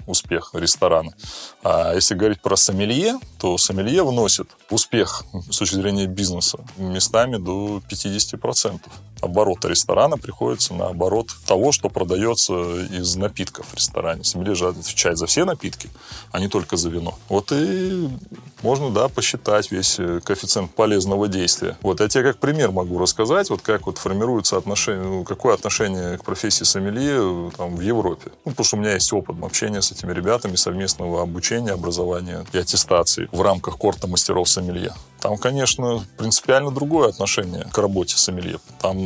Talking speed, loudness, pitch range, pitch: 150 wpm, -20 LUFS, 90-110 Hz, 95 Hz